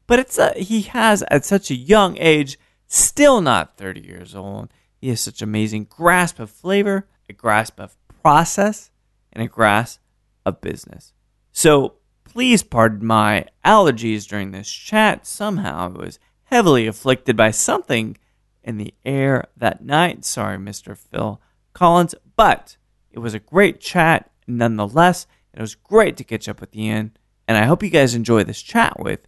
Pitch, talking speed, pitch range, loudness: 115 Hz, 165 wpm, 105-180 Hz, -17 LUFS